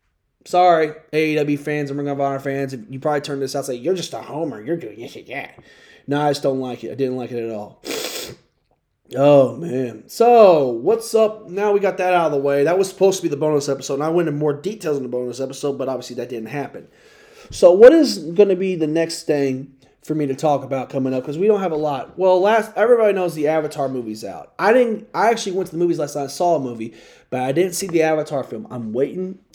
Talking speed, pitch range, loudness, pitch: 250 wpm, 135-185 Hz, -19 LUFS, 150 Hz